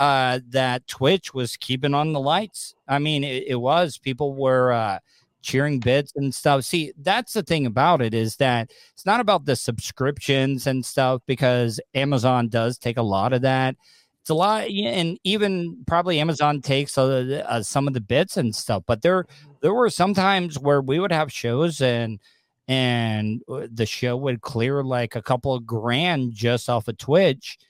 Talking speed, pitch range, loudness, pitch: 180 wpm, 125-150 Hz, -22 LUFS, 135 Hz